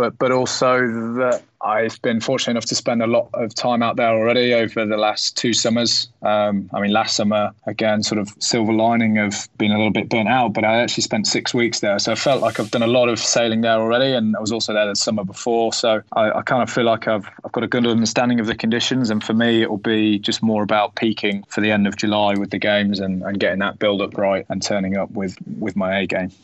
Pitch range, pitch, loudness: 105-115 Hz, 110 Hz, -19 LUFS